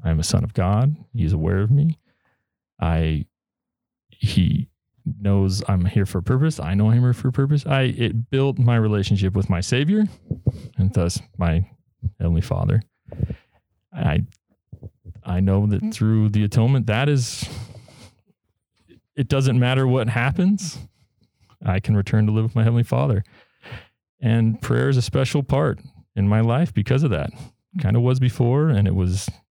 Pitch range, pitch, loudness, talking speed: 100-130 Hz, 115 Hz, -21 LUFS, 165 wpm